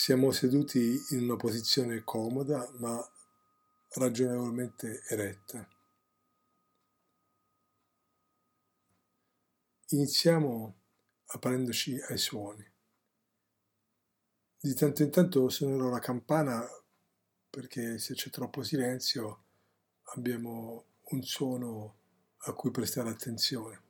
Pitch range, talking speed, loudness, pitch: 115-140 Hz, 80 wpm, -32 LUFS, 125 Hz